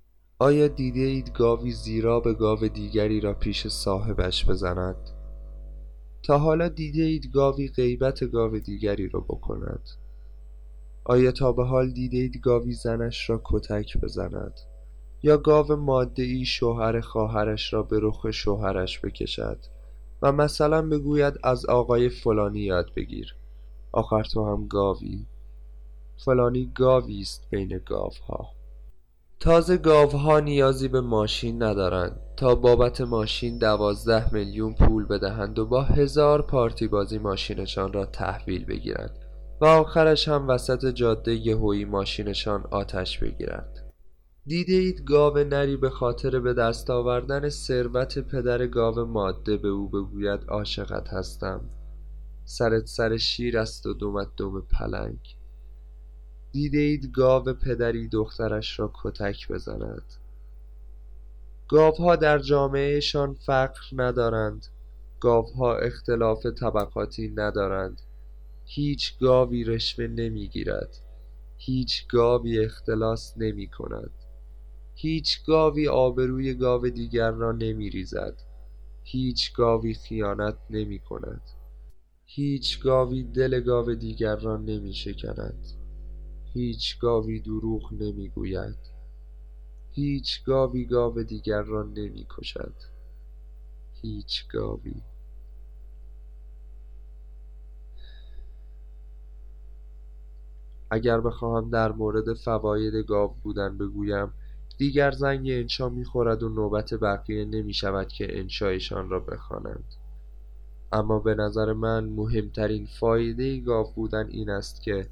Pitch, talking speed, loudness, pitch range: 110 Hz, 110 wpm, -25 LUFS, 80-125 Hz